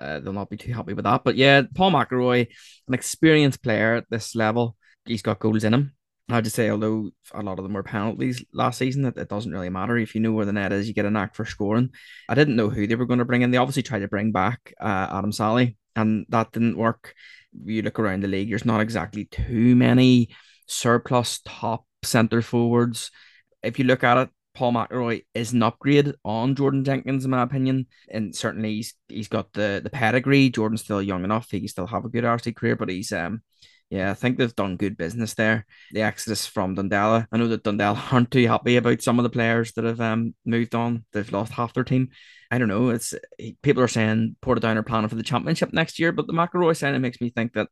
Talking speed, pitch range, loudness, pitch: 235 wpm, 105-125 Hz, -23 LUFS, 115 Hz